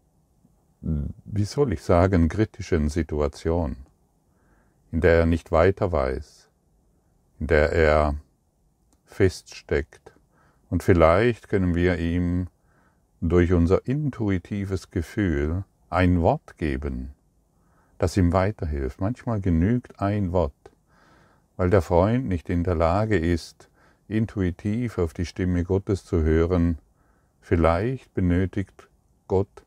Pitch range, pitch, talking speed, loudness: 80-100 Hz, 90 Hz, 105 wpm, -24 LUFS